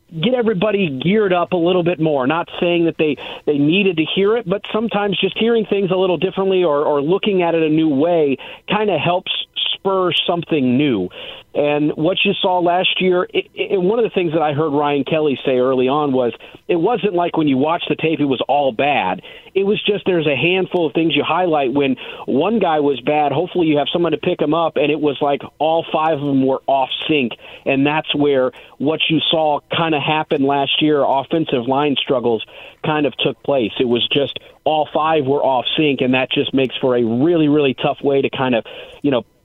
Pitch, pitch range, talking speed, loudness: 160 Hz, 145-185 Hz, 220 wpm, -17 LUFS